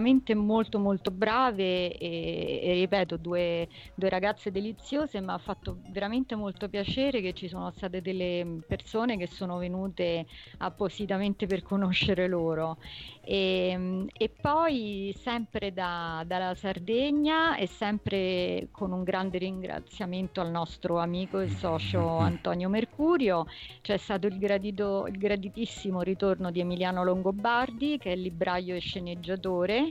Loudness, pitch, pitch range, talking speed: -30 LUFS, 190 Hz, 180-210 Hz, 130 wpm